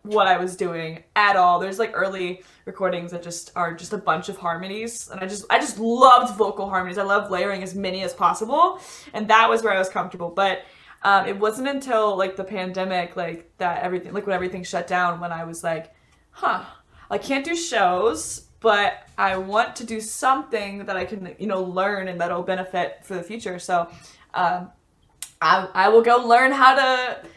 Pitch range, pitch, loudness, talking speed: 180-215 Hz, 190 Hz, -22 LUFS, 205 wpm